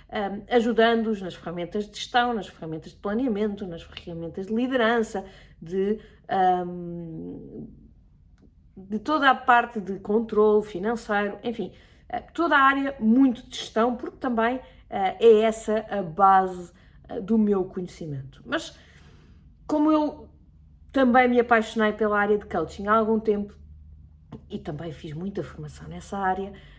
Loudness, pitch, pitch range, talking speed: -24 LUFS, 205 Hz, 170-230 Hz, 135 wpm